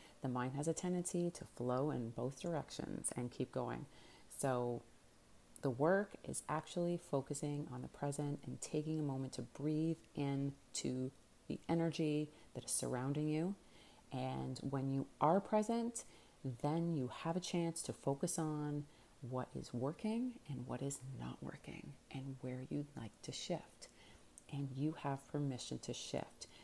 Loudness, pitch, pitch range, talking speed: -42 LUFS, 145 Hz, 130-160 Hz, 155 wpm